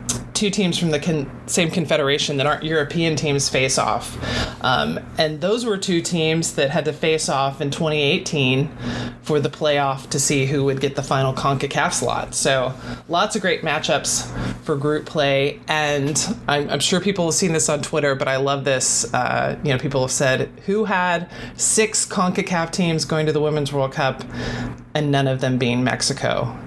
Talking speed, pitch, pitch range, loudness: 185 wpm, 150 Hz, 135-165 Hz, -20 LUFS